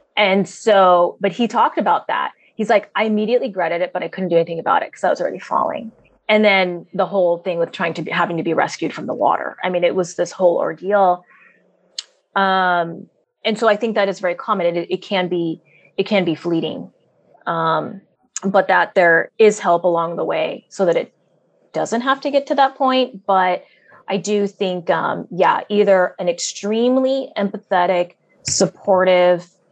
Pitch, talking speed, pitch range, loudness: 190 Hz, 195 wpm, 175-215 Hz, -18 LUFS